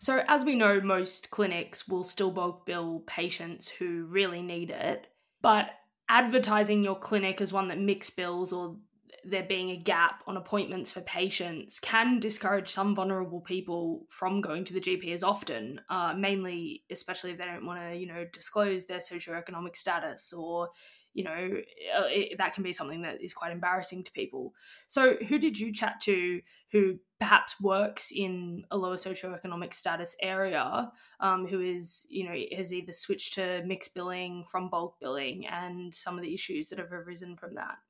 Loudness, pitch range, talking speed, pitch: -31 LUFS, 175-200 Hz, 175 wpm, 185 Hz